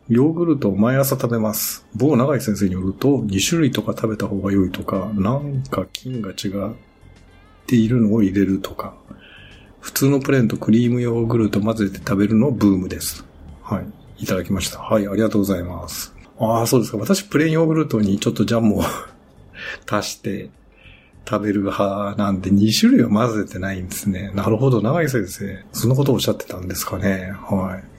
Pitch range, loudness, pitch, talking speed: 95-120 Hz, -20 LUFS, 105 Hz, 380 characters per minute